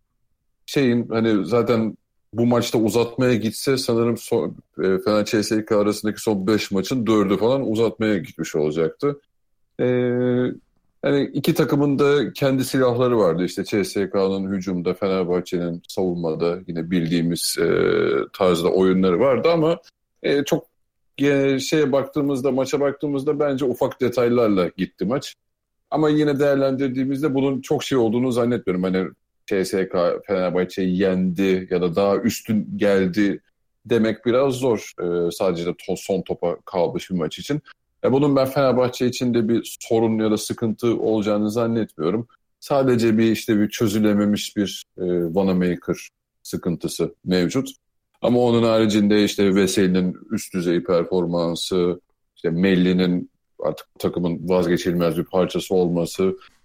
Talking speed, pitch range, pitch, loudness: 130 wpm, 95-130 Hz, 110 Hz, -21 LUFS